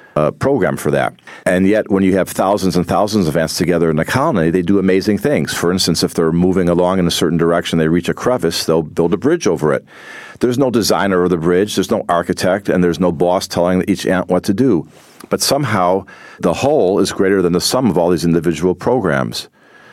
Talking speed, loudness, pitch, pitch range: 230 wpm, -15 LUFS, 90 Hz, 85-95 Hz